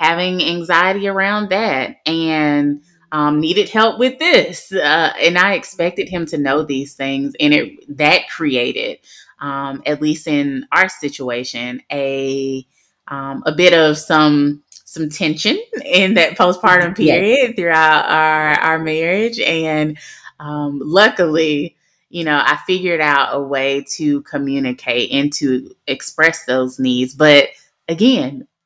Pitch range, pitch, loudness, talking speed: 140-180 Hz, 155 Hz, -15 LUFS, 135 wpm